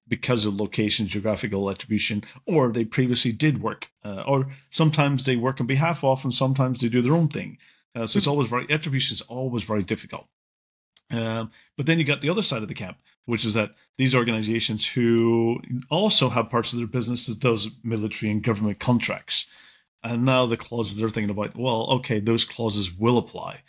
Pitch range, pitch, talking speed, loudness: 110-130 Hz, 120 Hz, 195 wpm, -24 LUFS